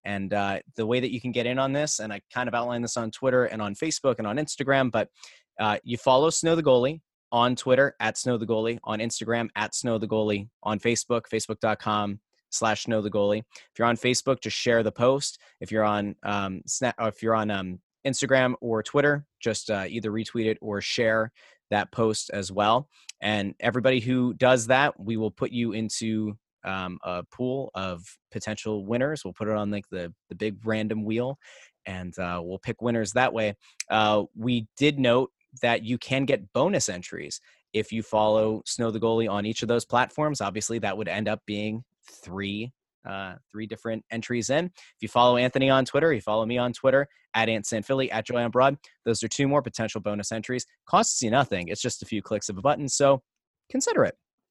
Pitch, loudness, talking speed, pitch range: 115 Hz, -26 LUFS, 205 wpm, 105-125 Hz